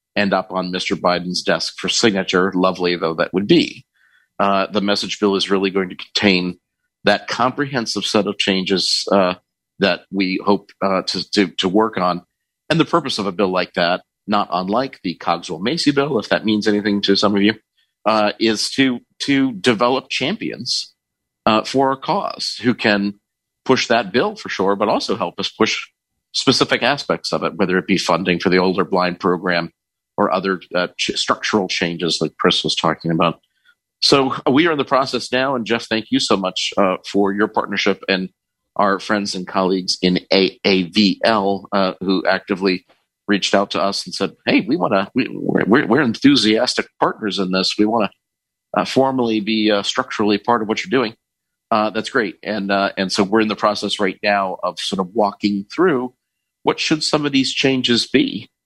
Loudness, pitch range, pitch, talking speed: -18 LUFS, 95-115 Hz, 100 Hz, 190 wpm